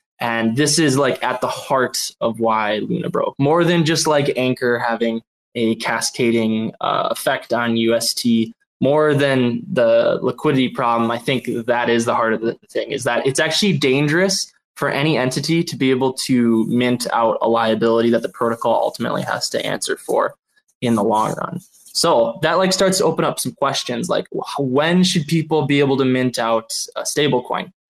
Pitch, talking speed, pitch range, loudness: 130 Hz, 185 wpm, 115-160 Hz, -18 LUFS